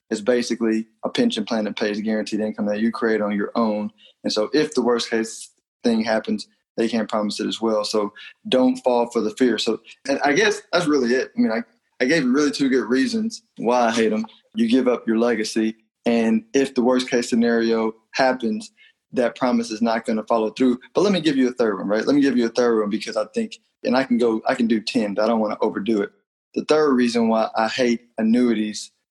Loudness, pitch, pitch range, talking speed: -21 LUFS, 115 Hz, 110-130 Hz, 245 wpm